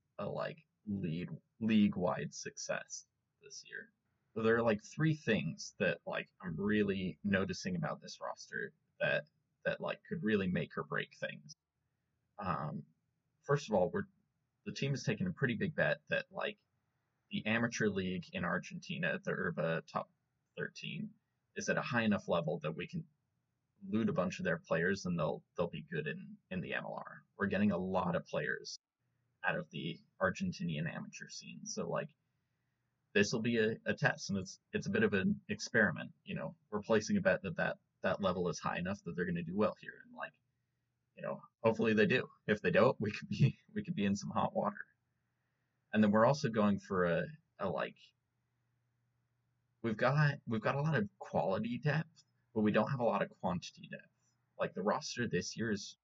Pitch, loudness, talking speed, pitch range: 155 Hz, -36 LUFS, 190 wpm, 120-195 Hz